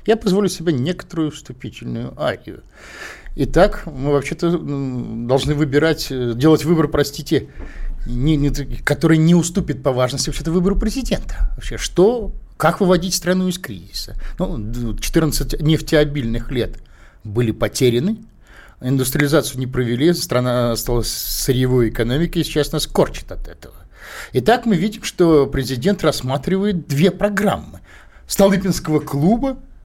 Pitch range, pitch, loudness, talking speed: 130-175 Hz, 150 Hz, -18 LUFS, 120 wpm